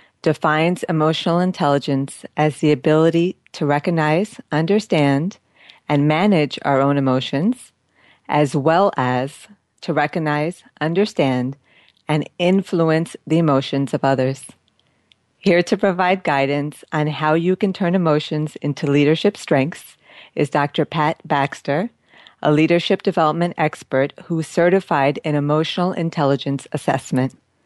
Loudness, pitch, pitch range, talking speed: -19 LUFS, 155 Hz, 140-175 Hz, 115 wpm